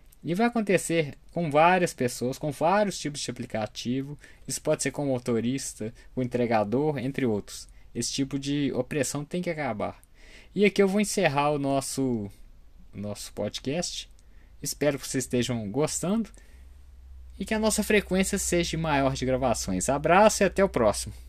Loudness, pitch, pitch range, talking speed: -27 LUFS, 135 Hz, 120-170 Hz, 160 wpm